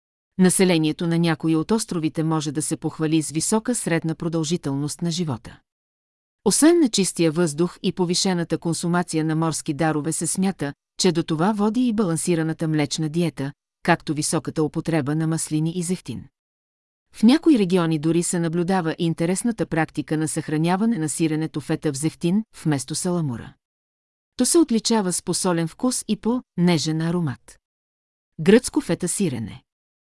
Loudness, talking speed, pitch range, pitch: -22 LUFS, 145 wpm, 155-180 Hz, 165 Hz